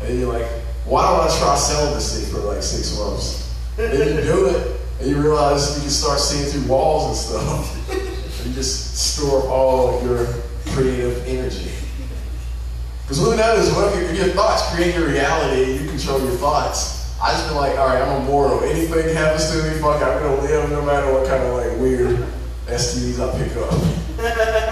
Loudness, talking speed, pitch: -19 LUFS, 190 wpm, 130 Hz